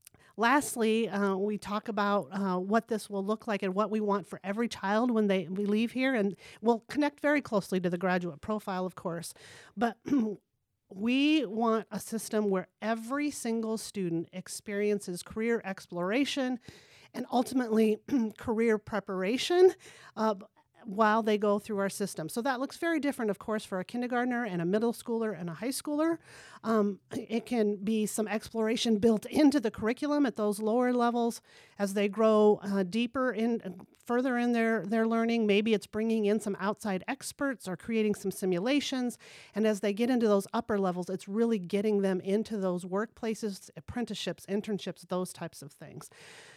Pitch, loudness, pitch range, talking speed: 215 Hz, -30 LUFS, 200-235 Hz, 170 wpm